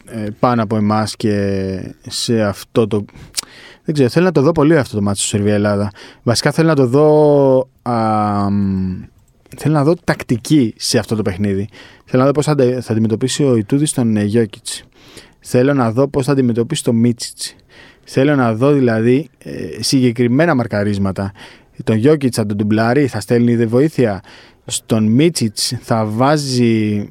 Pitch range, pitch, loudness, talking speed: 110-135 Hz, 120 Hz, -15 LUFS, 155 wpm